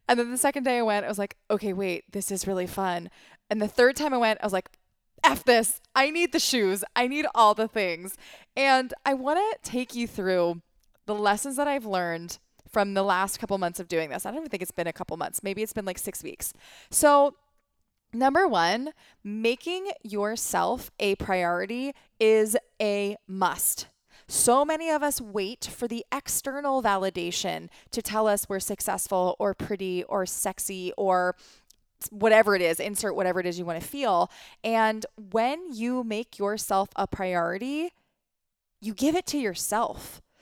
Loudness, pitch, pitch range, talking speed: -26 LUFS, 210 Hz, 195-255 Hz, 185 wpm